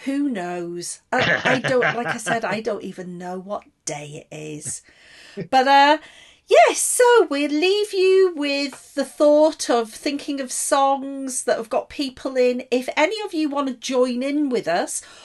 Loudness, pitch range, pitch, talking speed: -20 LUFS, 220-295 Hz, 275 Hz, 180 wpm